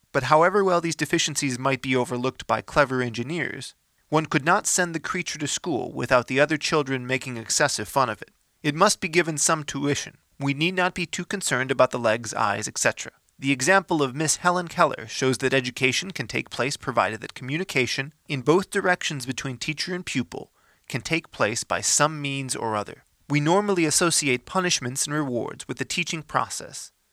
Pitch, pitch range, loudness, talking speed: 150 Hz, 130-175 Hz, -24 LUFS, 190 wpm